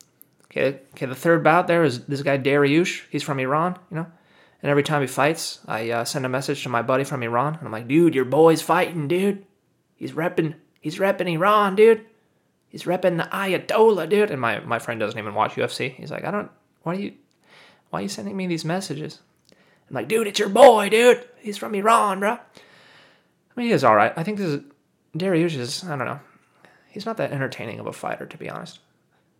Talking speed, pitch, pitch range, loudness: 220 wpm, 165 Hz, 145-200 Hz, -21 LUFS